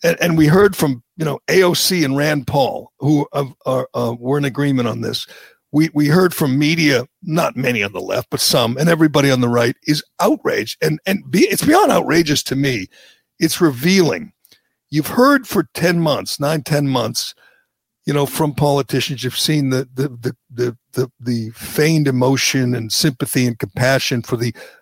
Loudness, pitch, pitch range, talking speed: -17 LUFS, 145 Hz, 130-155 Hz, 190 wpm